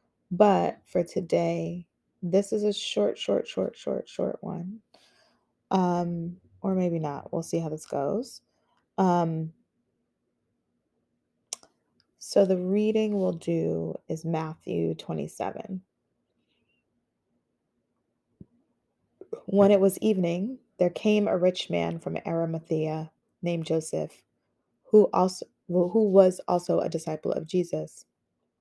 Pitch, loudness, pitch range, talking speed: 175 Hz, -27 LUFS, 160-195 Hz, 115 wpm